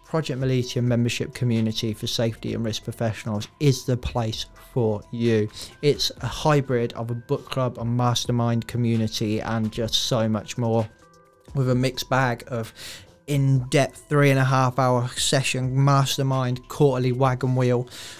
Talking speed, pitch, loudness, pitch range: 150 wpm, 125 Hz, -23 LUFS, 115-130 Hz